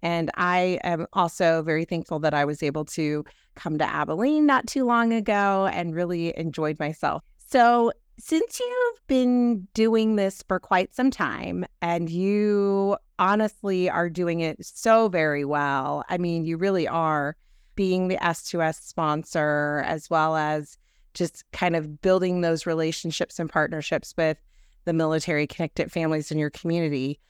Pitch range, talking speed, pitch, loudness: 155-195 Hz, 150 wpm, 170 Hz, -24 LUFS